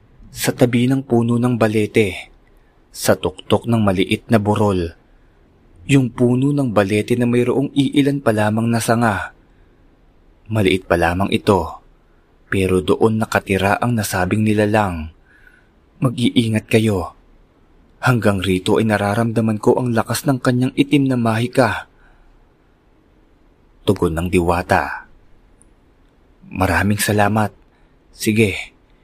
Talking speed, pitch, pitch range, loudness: 110 wpm, 110 Hz, 95-120 Hz, -17 LUFS